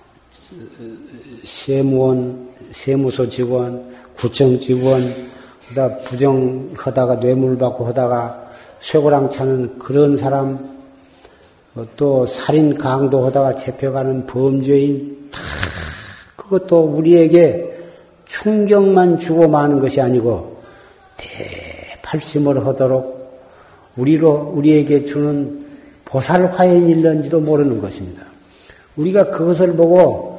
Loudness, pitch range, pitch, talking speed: -15 LUFS, 125-155 Hz, 135 Hz, 210 characters per minute